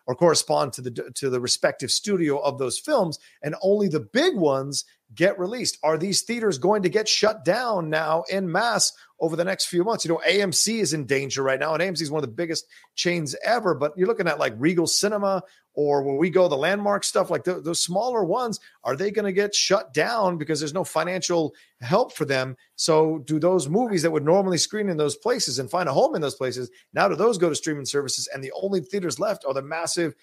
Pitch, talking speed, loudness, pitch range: 170 Hz, 230 wpm, -23 LUFS, 145-190 Hz